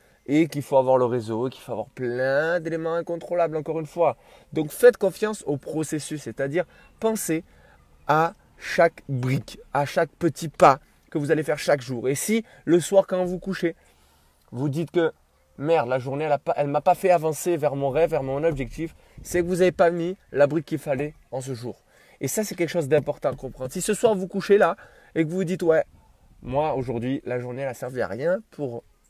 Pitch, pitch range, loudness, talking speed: 155 Hz, 135-175 Hz, -24 LUFS, 210 wpm